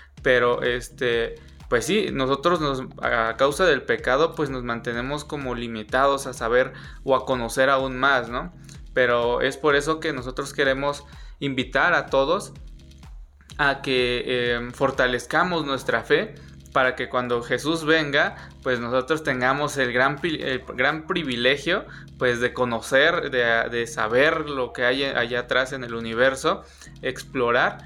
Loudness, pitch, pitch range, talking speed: -23 LUFS, 130 Hz, 120-140 Hz, 145 wpm